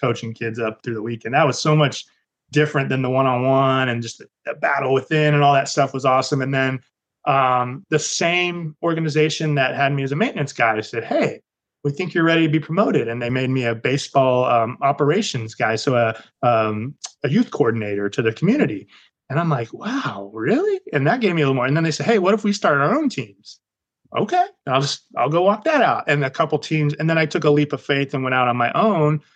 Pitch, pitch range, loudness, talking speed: 140 Hz, 125-160 Hz, -19 LUFS, 235 wpm